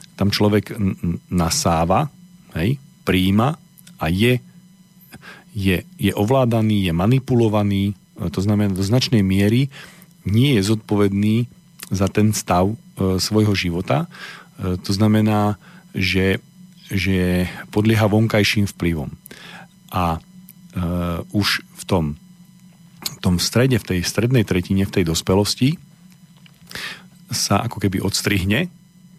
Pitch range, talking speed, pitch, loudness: 95-160 Hz, 115 wpm, 105 Hz, -19 LUFS